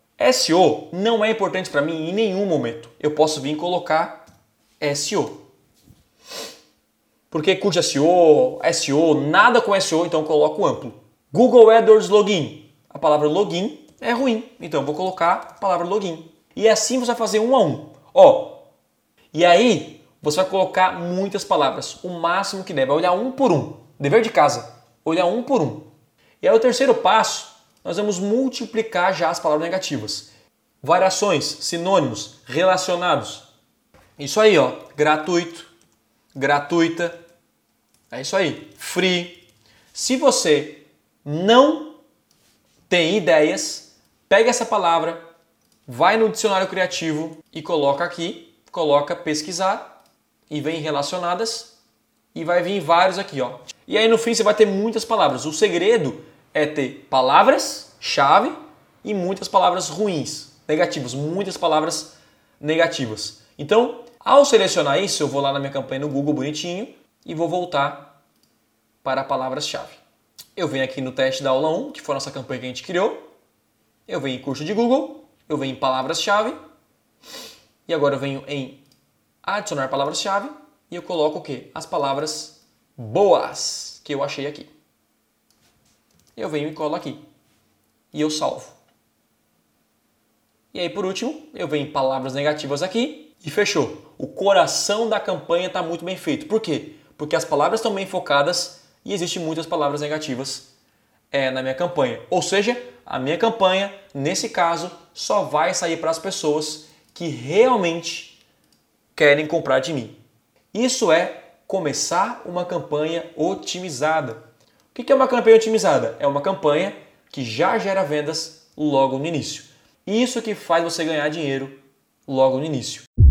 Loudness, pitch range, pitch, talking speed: -20 LUFS, 145-200 Hz, 165 Hz, 150 wpm